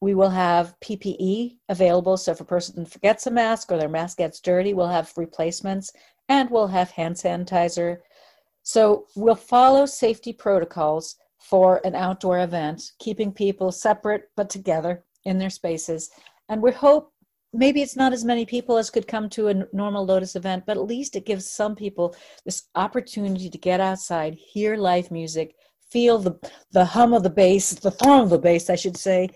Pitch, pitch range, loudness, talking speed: 195 Hz, 180-220 Hz, -22 LUFS, 180 wpm